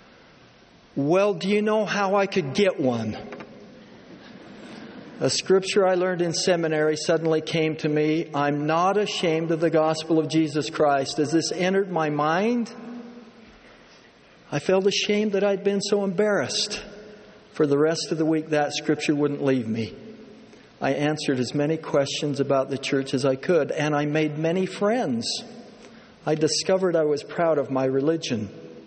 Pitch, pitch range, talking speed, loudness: 160 Hz, 150-200 Hz, 160 wpm, -23 LUFS